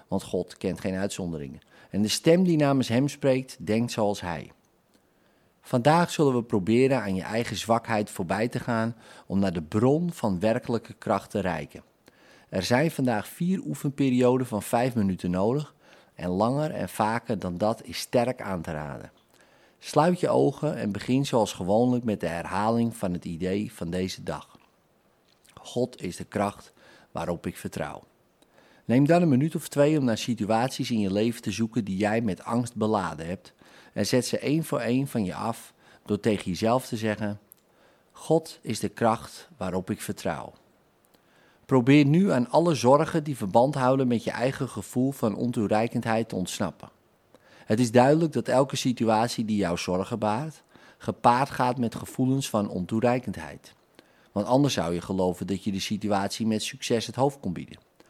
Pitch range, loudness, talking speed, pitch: 100-130 Hz, -26 LUFS, 170 wpm, 115 Hz